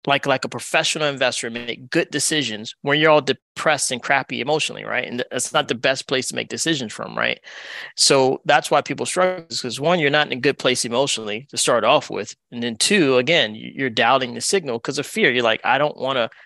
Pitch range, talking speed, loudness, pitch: 120-150 Hz, 225 wpm, -19 LUFS, 135 Hz